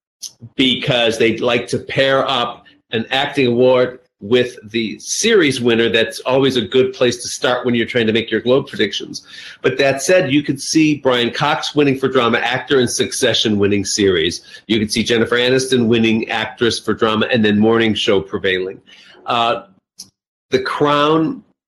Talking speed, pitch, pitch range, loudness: 170 wpm, 125 Hz, 115-135 Hz, -16 LUFS